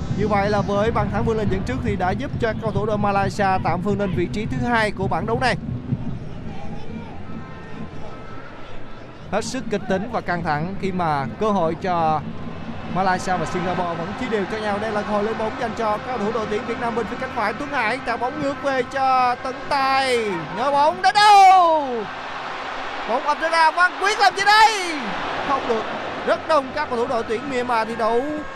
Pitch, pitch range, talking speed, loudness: 230 Hz, 200-270 Hz, 210 wpm, -21 LUFS